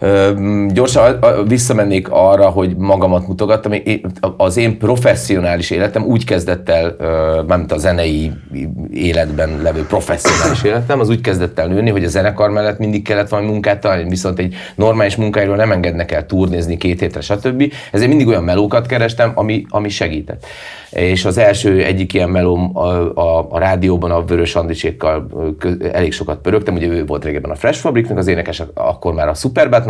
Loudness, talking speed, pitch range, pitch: -14 LUFS, 170 wpm, 85-105 Hz, 95 Hz